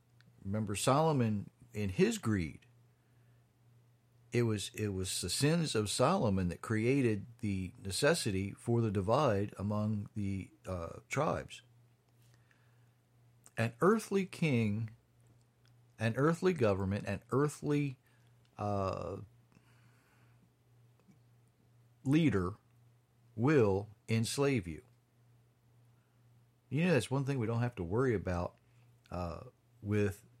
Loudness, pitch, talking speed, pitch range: -34 LUFS, 120 Hz, 100 wpm, 105-120 Hz